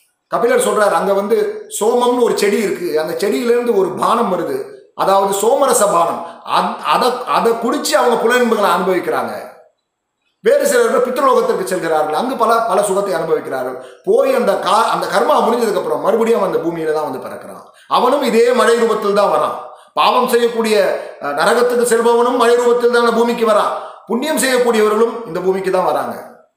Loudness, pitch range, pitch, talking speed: -15 LUFS, 195-250 Hz, 230 Hz, 150 wpm